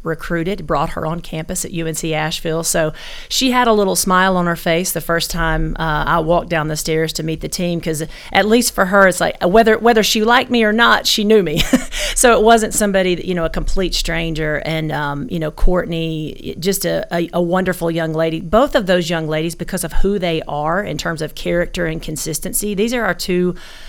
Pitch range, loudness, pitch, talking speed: 160-195 Hz, -16 LUFS, 170 Hz, 225 wpm